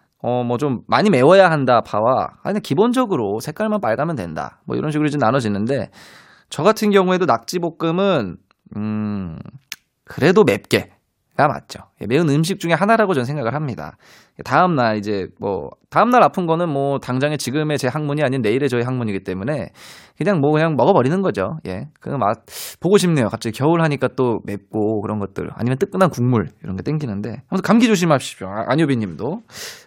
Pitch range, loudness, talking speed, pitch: 115-175 Hz, -18 LUFS, 370 characters per minute, 145 Hz